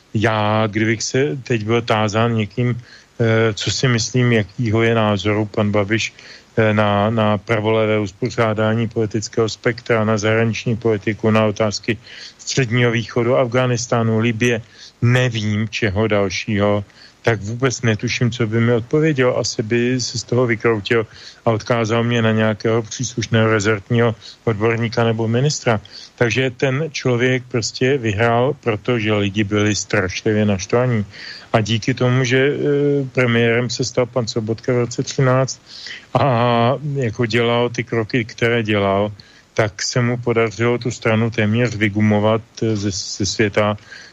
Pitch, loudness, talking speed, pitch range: 115 Hz, -18 LUFS, 130 wpm, 110-125 Hz